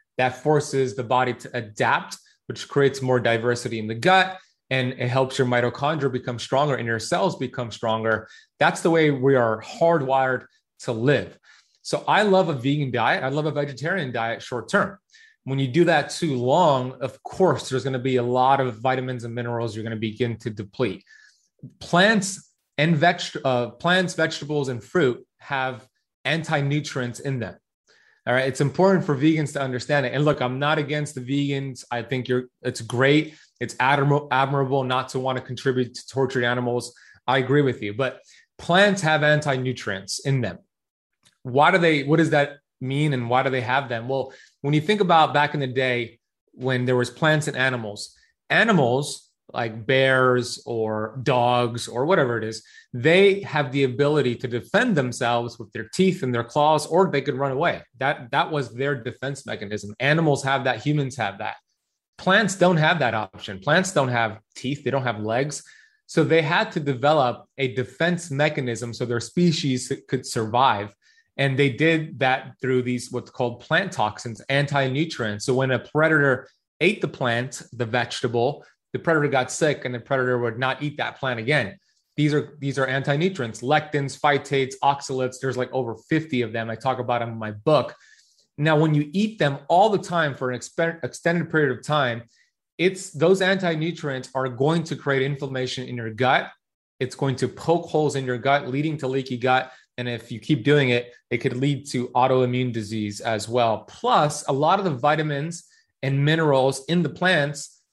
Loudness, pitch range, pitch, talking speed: -23 LUFS, 125-150 Hz, 135 Hz, 185 wpm